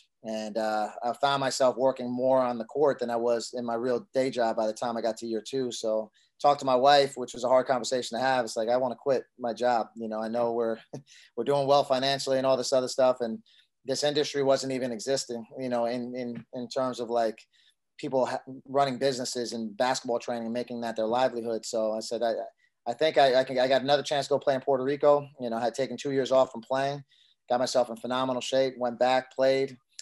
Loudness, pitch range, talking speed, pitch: -28 LUFS, 115-135 Hz, 245 wpm, 125 Hz